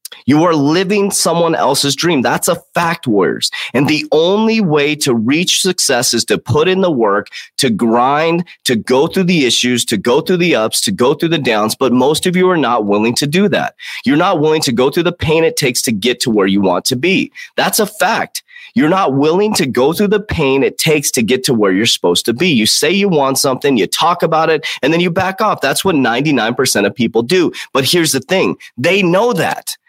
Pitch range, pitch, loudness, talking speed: 130-190 Hz, 160 Hz, -13 LUFS, 235 wpm